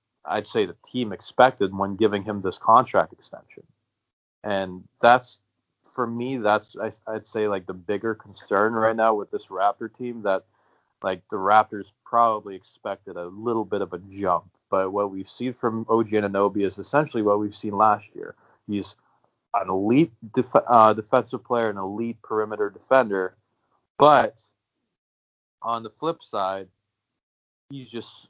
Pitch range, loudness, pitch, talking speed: 100-115 Hz, -23 LUFS, 105 Hz, 155 wpm